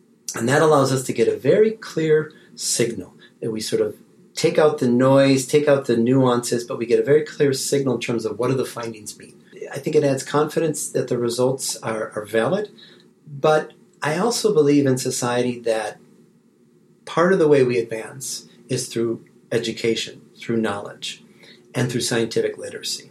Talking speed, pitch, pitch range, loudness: 180 wpm, 130 Hz, 120-155 Hz, -20 LUFS